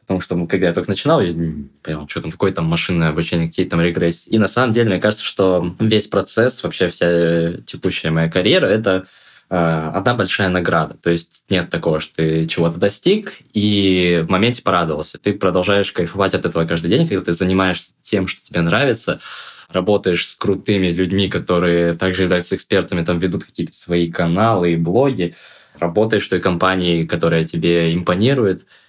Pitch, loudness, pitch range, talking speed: 90 Hz, -17 LUFS, 85-95 Hz, 175 wpm